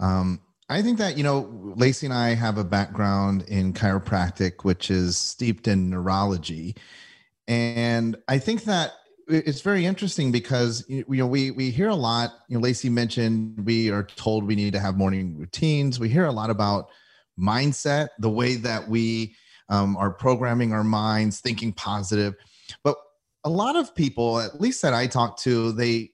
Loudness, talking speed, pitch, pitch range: -24 LUFS, 175 wpm, 115 Hz, 100-130 Hz